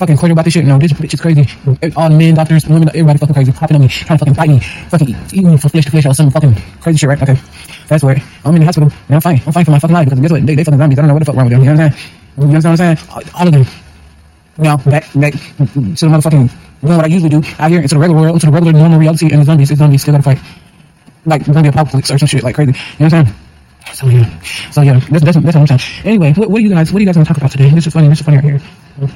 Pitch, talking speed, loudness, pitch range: 150 Hz, 350 wpm, -9 LUFS, 140-160 Hz